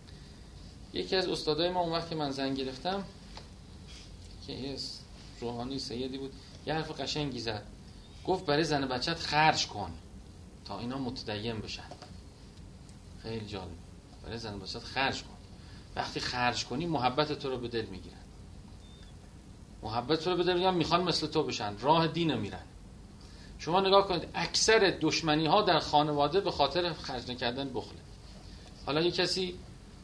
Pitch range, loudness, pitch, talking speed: 95-155 Hz, -31 LUFS, 125 Hz, 145 wpm